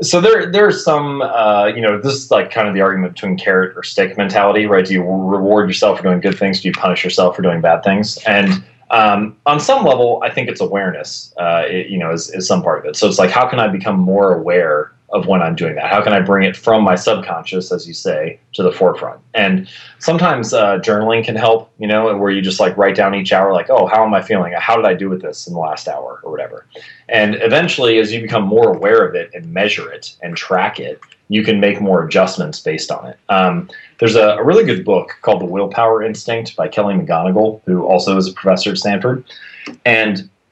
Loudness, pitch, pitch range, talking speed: -14 LUFS, 105 Hz, 95-115 Hz, 240 wpm